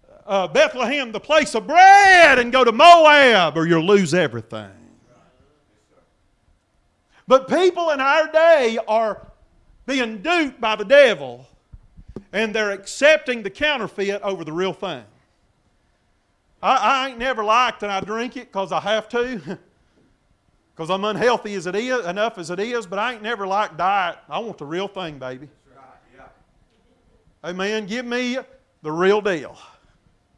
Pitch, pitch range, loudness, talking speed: 215 Hz, 185-255 Hz, -17 LUFS, 150 wpm